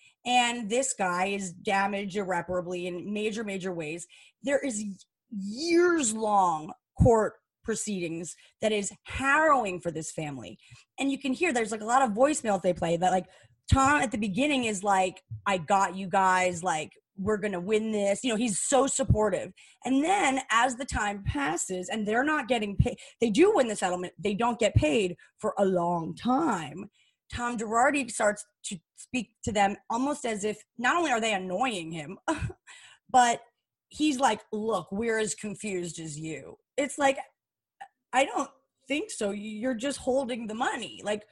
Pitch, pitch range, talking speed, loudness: 215 Hz, 190-260 Hz, 170 wpm, -28 LUFS